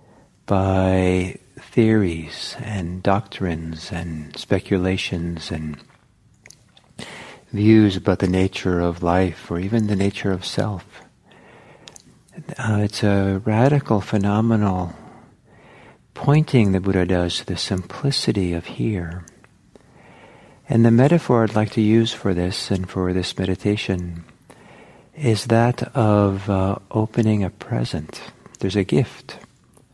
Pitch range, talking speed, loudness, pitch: 90-110 Hz, 110 wpm, -20 LUFS, 100 Hz